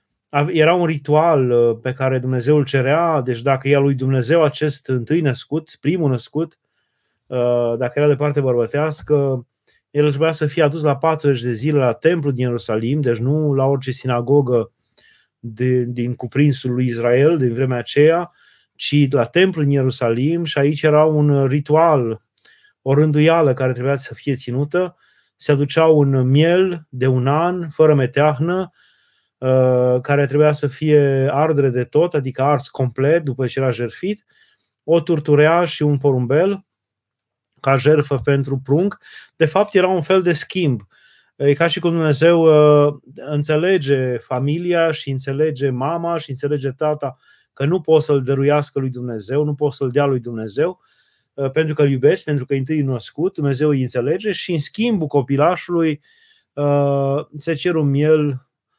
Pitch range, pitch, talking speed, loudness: 130-155 Hz, 145 Hz, 155 wpm, -17 LUFS